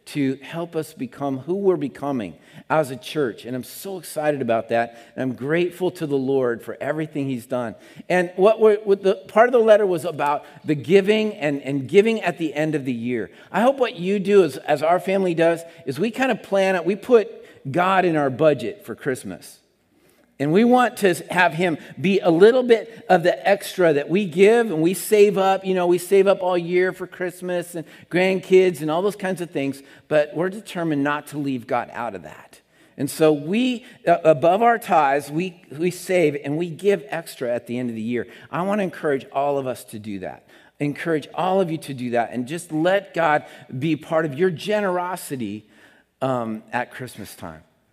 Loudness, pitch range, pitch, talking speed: -21 LUFS, 140-190 Hz, 170 Hz, 210 wpm